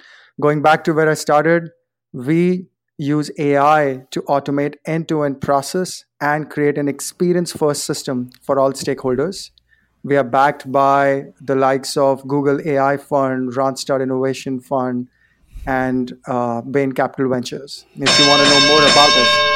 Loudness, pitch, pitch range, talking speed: -16 LUFS, 140 Hz, 135-150 Hz, 145 wpm